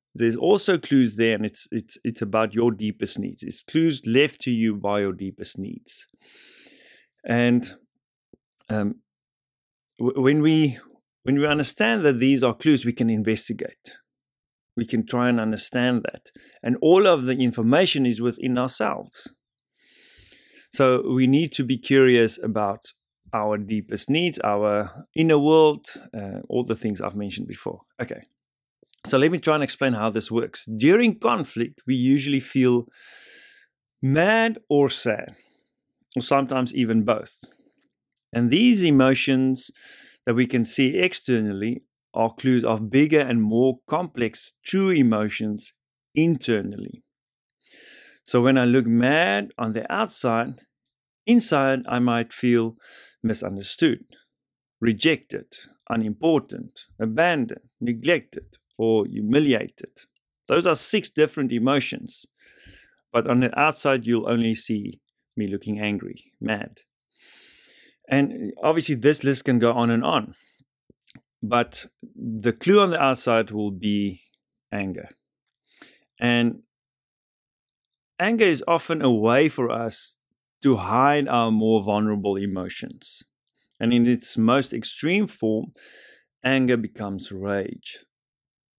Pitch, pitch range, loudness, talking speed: 120 Hz, 110-140 Hz, -22 LUFS, 125 wpm